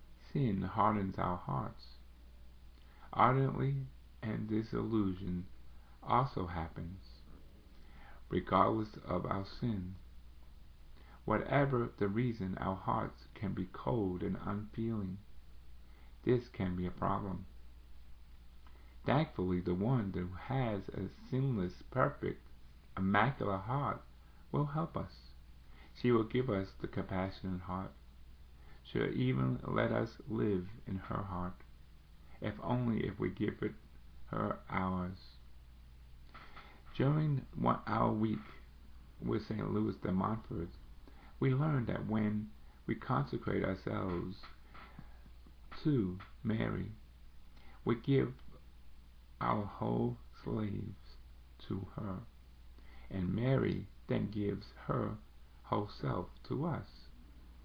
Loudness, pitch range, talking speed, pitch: -37 LUFS, 65-105 Hz, 100 wpm, 90 Hz